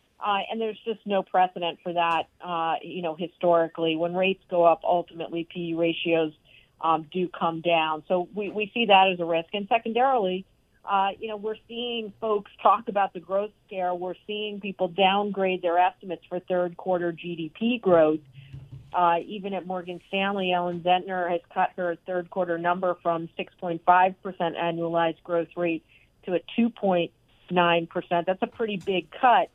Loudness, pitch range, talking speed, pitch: -26 LUFS, 170-195 Hz, 165 wpm, 180 Hz